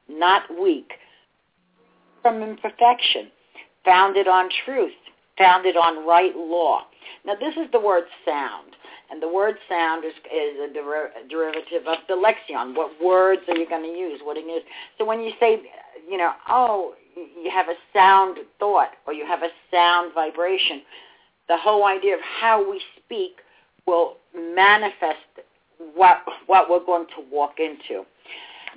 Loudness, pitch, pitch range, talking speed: -21 LUFS, 185 Hz, 170-225 Hz, 155 wpm